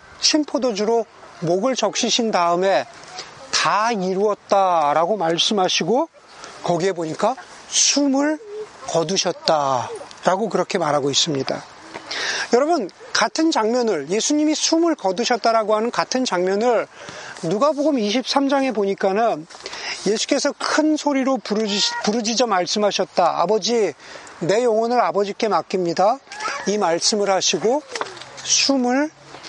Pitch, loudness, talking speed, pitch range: 220 Hz, -19 LUFS, 260 characters per minute, 190-265 Hz